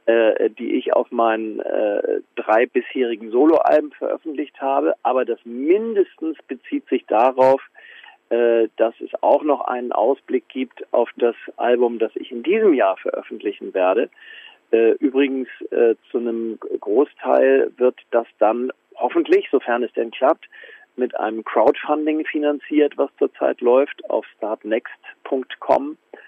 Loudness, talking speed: -20 LUFS, 130 wpm